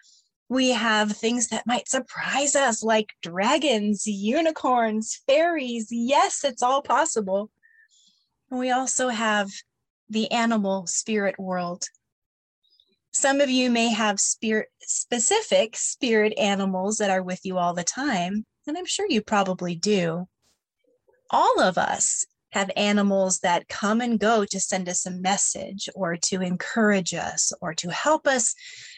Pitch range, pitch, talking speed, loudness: 195-260 Hz, 220 Hz, 140 wpm, -23 LUFS